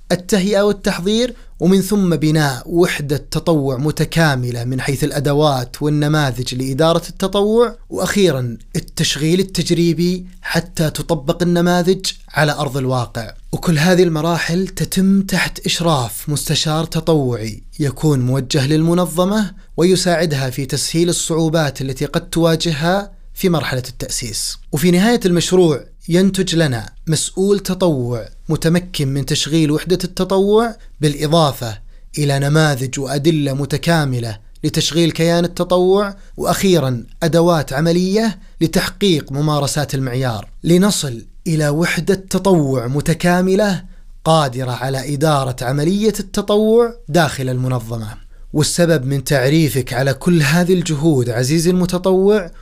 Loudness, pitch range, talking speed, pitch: -16 LUFS, 140-180 Hz, 105 wpm, 160 Hz